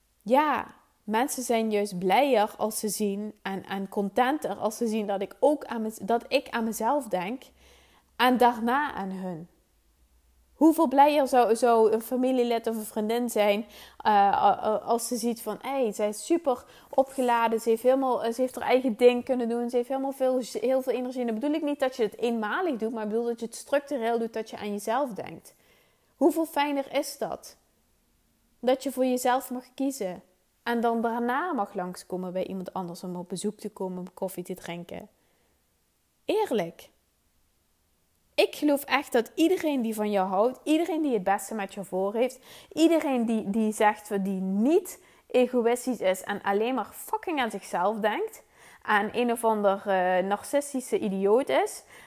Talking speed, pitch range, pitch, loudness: 180 wpm, 200-260 Hz, 230 Hz, -27 LUFS